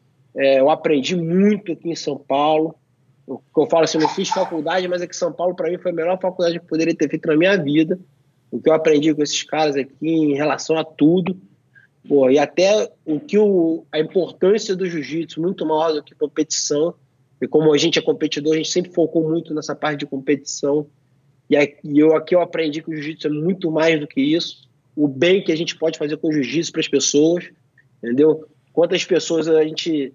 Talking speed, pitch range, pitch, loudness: 215 wpm, 145-170 Hz, 155 Hz, -19 LUFS